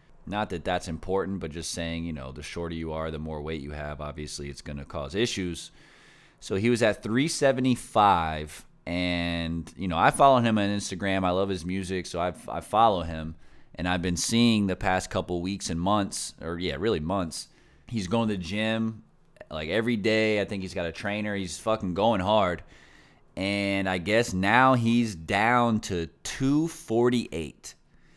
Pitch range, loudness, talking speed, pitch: 85-110 Hz, -27 LUFS, 185 wpm, 95 Hz